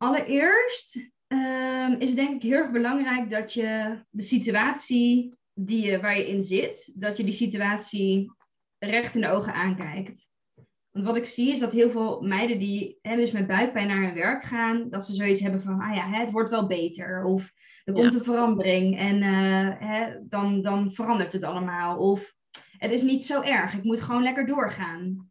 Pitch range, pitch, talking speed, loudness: 195-240 Hz, 215 Hz, 190 wpm, -25 LUFS